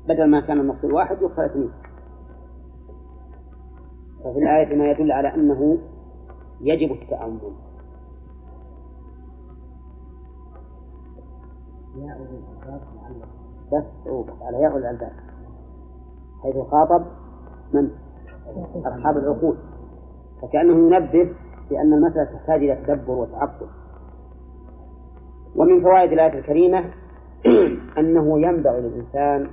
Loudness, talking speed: -19 LUFS, 80 wpm